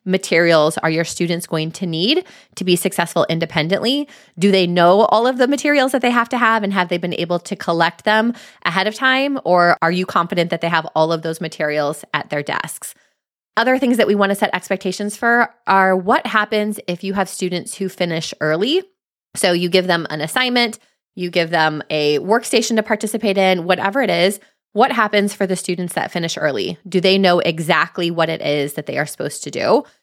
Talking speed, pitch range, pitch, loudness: 210 wpm, 170-215 Hz, 185 Hz, -17 LUFS